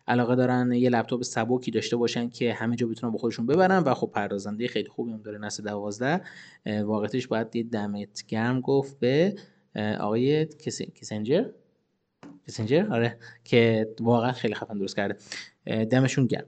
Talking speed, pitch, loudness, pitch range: 155 wpm, 115 Hz, -27 LUFS, 110-125 Hz